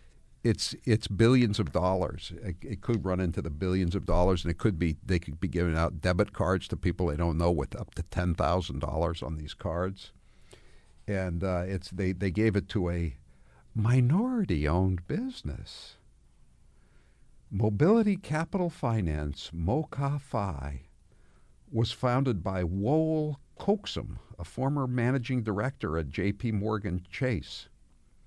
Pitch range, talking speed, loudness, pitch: 85-115 Hz, 140 wpm, -30 LUFS, 95 Hz